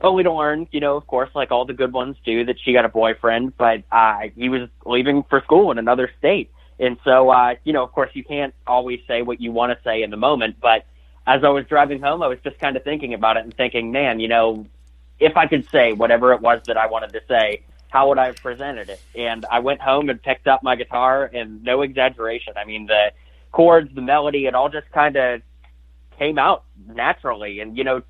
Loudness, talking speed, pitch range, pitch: -18 LUFS, 235 wpm, 115-135 Hz, 125 Hz